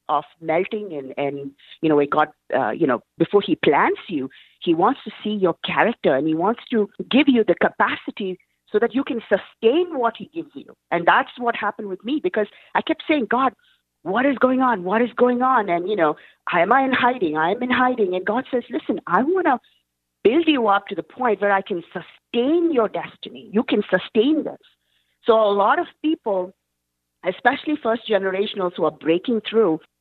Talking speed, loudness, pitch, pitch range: 205 wpm, -21 LUFS, 220 Hz, 185-265 Hz